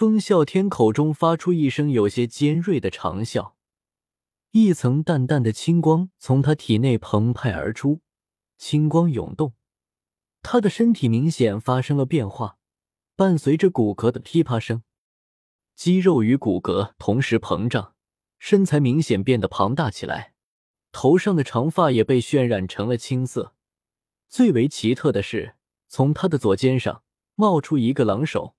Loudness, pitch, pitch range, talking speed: -21 LUFS, 130 Hz, 110-160 Hz, 220 characters per minute